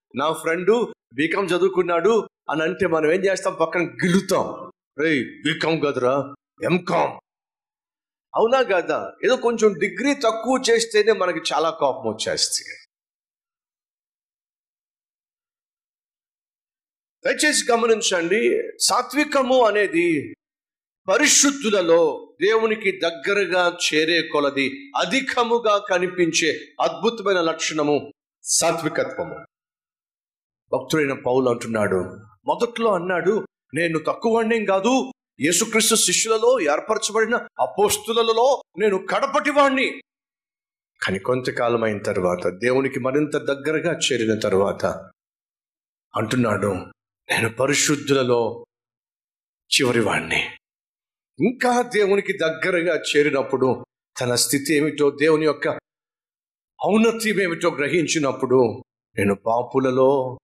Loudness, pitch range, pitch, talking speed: -20 LUFS, 140-230 Hz, 180 Hz, 80 wpm